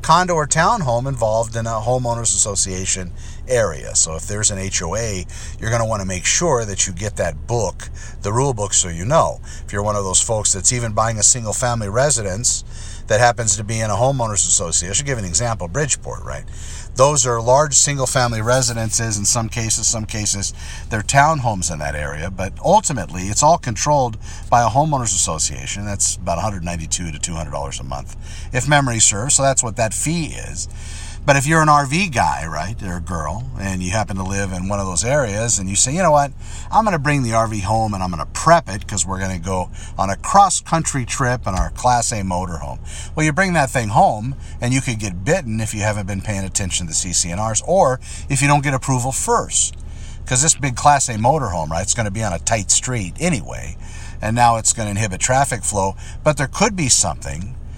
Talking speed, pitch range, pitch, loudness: 220 wpm, 90-125 Hz, 105 Hz, -18 LUFS